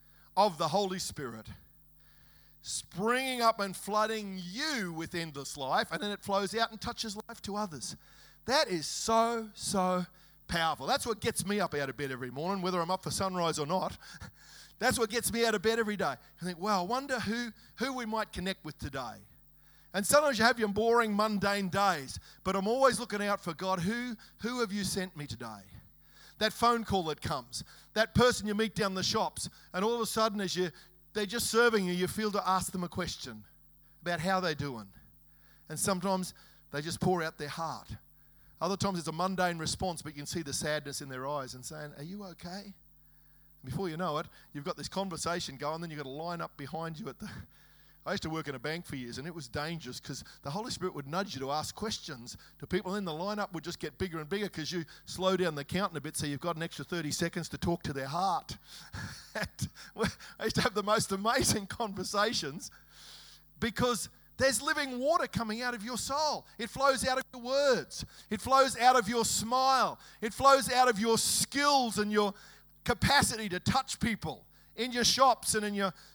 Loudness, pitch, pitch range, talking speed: -32 LUFS, 190 Hz, 160-225 Hz, 215 wpm